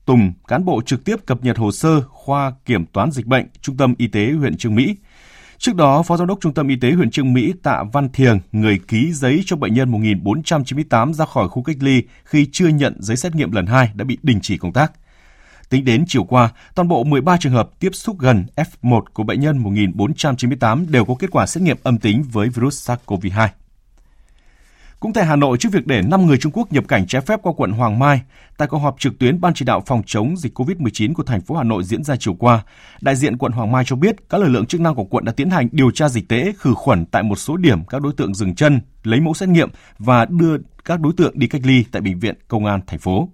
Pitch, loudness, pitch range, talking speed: 130 Hz, -17 LUFS, 110-155 Hz, 250 wpm